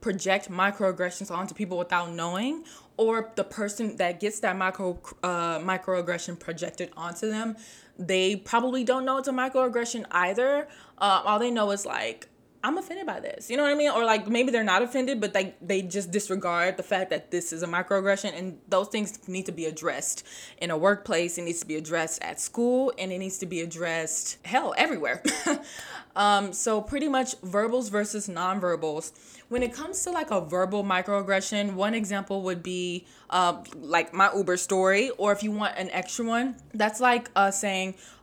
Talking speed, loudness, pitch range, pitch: 190 wpm, -27 LUFS, 180-225 Hz, 195 Hz